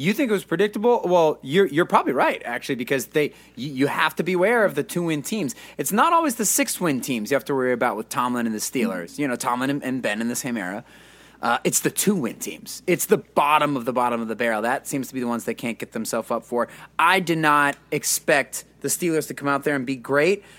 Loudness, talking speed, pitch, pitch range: -22 LUFS, 255 wpm, 145 Hz, 130-185 Hz